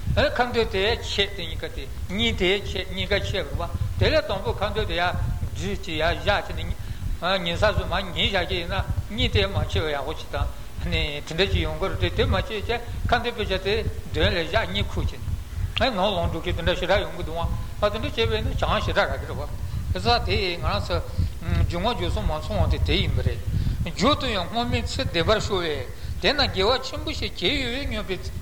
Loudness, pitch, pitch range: -25 LUFS, 95 Hz, 90-100 Hz